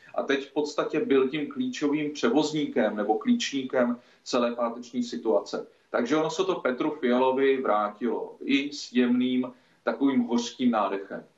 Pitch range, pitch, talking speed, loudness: 120-150 Hz, 130 Hz, 135 wpm, -27 LUFS